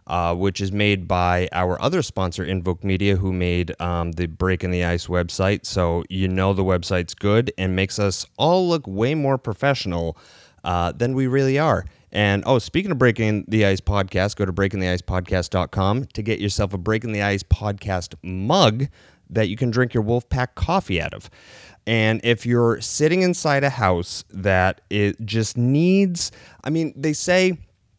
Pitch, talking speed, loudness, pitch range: 100 Hz, 180 wpm, -21 LUFS, 90-120 Hz